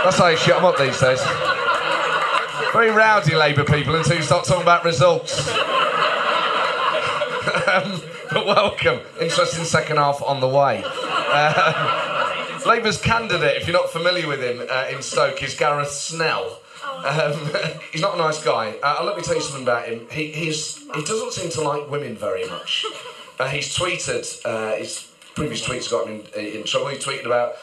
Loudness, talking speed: -20 LUFS, 175 wpm